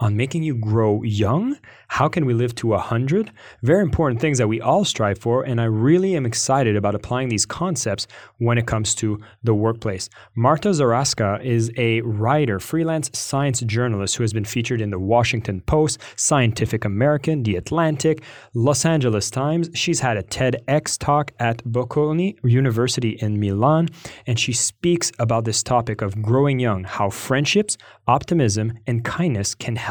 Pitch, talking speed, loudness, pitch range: 120 Hz, 165 wpm, -20 LUFS, 110-150 Hz